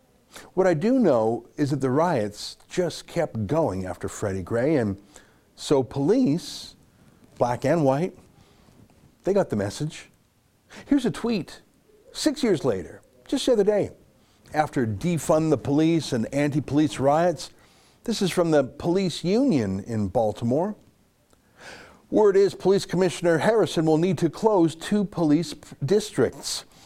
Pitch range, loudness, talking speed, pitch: 125-185 Hz, -24 LUFS, 140 wpm, 155 Hz